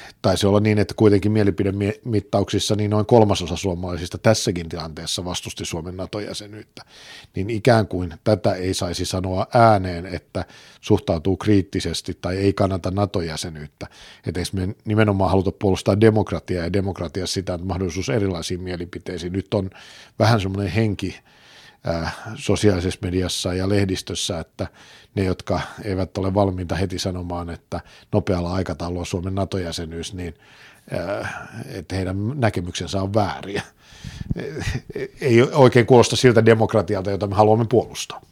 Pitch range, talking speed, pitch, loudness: 90-105 Hz, 125 wpm, 95 Hz, -21 LUFS